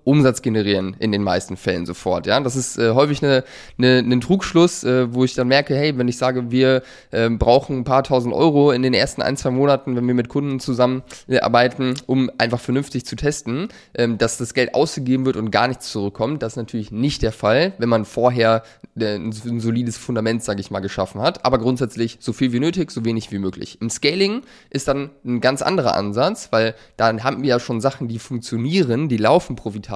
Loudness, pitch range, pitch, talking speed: -19 LUFS, 115-135 Hz, 125 Hz, 210 wpm